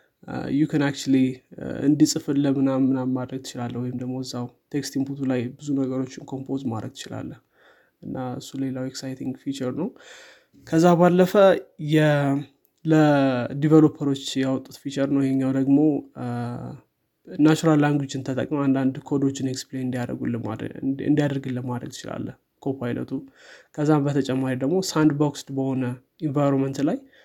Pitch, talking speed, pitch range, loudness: 135 Hz, 110 wpm, 130-145 Hz, -23 LUFS